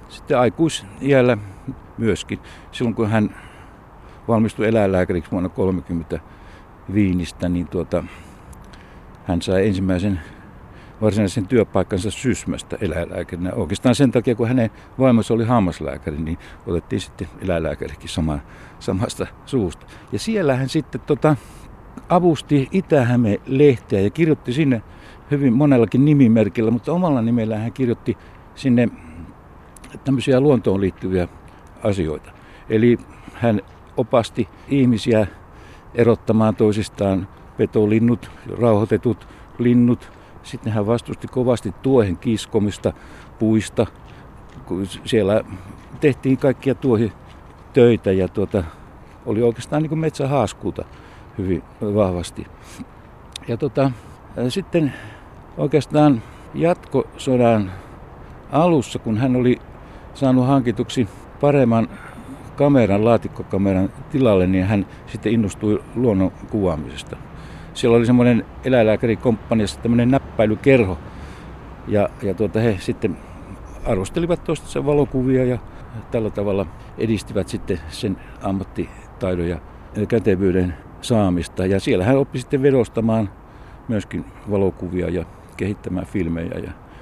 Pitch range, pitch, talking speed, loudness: 90-125 Hz, 110 Hz, 100 wpm, -20 LUFS